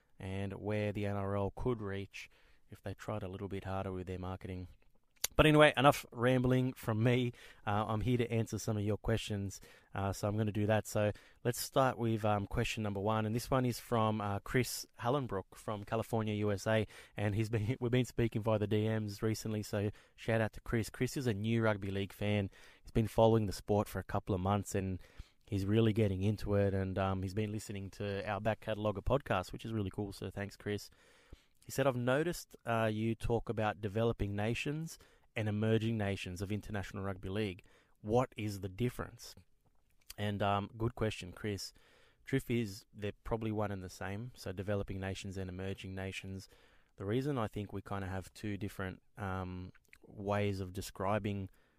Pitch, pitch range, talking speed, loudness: 105 Hz, 100-115 Hz, 195 wpm, -36 LUFS